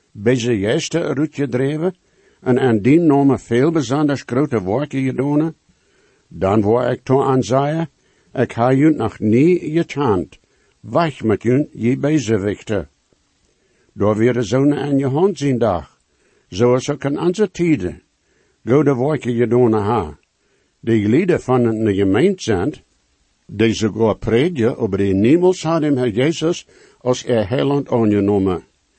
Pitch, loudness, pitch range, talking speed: 130 Hz, -17 LUFS, 115-150 Hz, 145 wpm